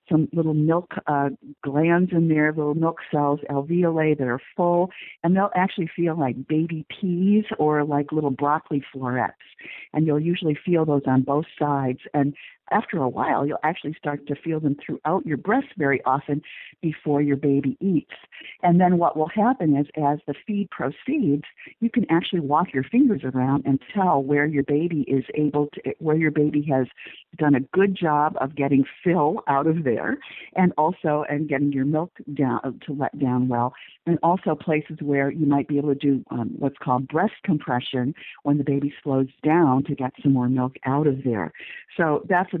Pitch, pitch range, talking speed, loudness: 150 Hz, 140-165 Hz, 190 wpm, -23 LUFS